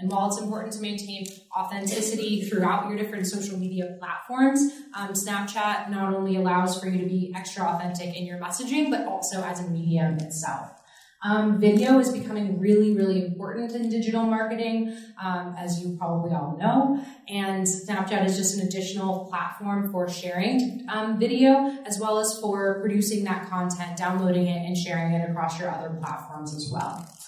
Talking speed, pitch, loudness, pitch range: 170 wpm, 195 Hz, -26 LUFS, 180-215 Hz